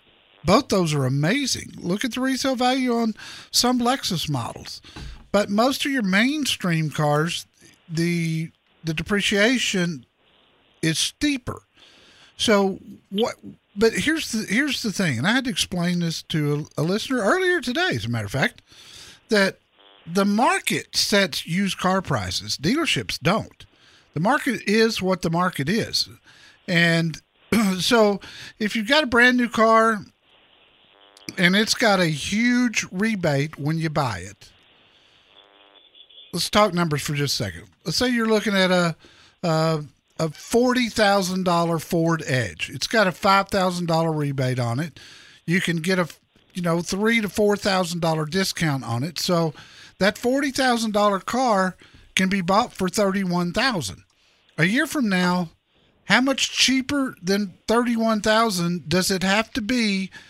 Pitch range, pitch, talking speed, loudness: 160-225 Hz, 190 Hz, 155 wpm, -22 LUFS